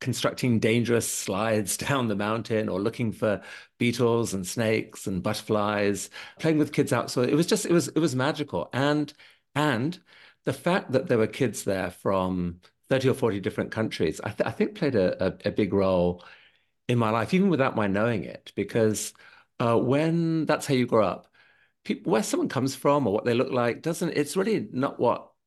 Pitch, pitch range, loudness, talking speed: 120 Hz, 105-145 Hz, -26 LUFS, 195 wpm